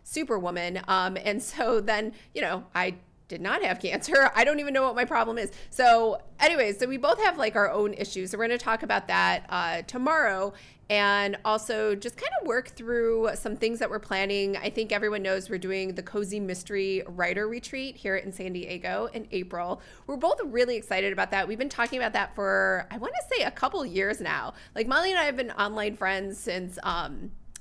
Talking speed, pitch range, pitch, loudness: 215 wpm, 195-240 Hz, 210 Hz, -27 LUFS